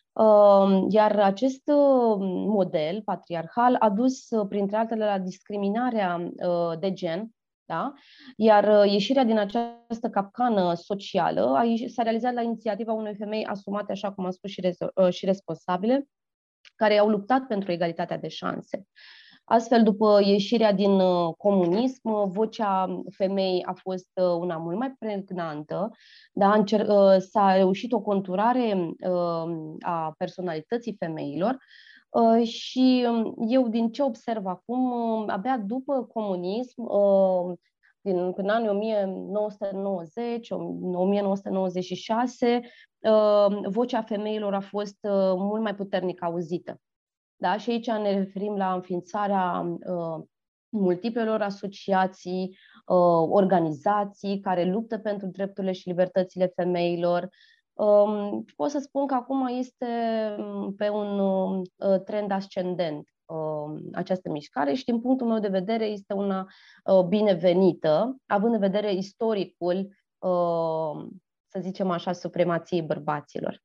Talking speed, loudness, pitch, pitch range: 115 wpm, -25 LUFS, 200 Hz, 185-225 Hz